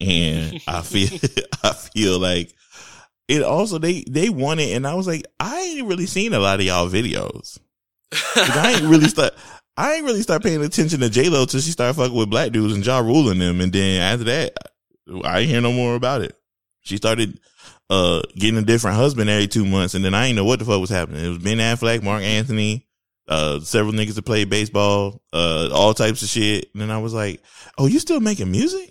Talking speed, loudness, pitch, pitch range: 220 wpm, -19 LUFS, 110 Hz, 95-130 Hz